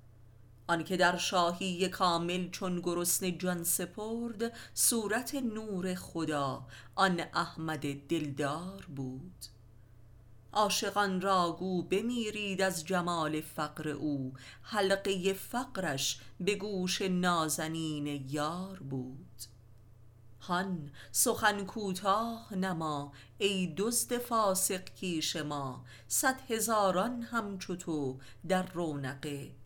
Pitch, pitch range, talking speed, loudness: 175 Hz, 140-195 Hz, 90 wpm, -33 LUFS